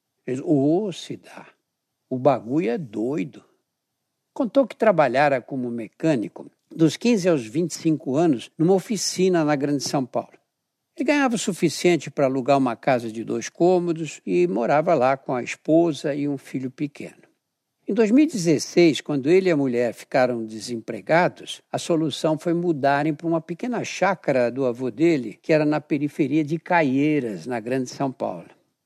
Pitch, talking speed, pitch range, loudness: 155 Hz, 155 wpm, 135-175 Hz, -22 LUFS